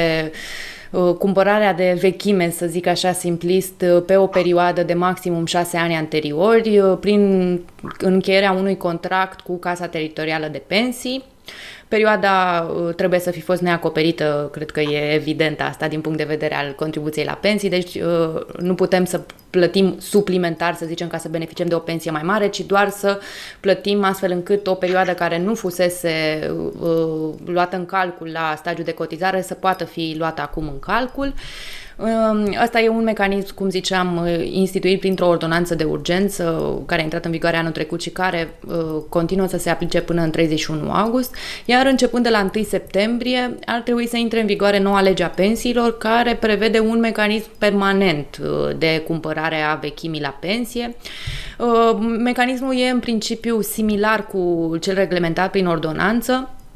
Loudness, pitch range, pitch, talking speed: -19 LUFS, 165-205 Hz, 180 Hz, 165 wpm